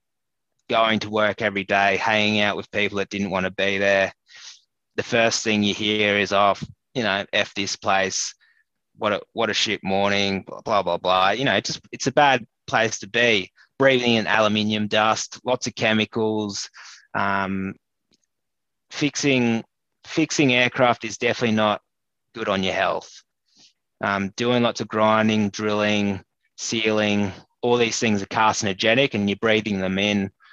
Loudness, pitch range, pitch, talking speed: -21 LUFS, 100-115 Hz, 105 Hz, 160 wpm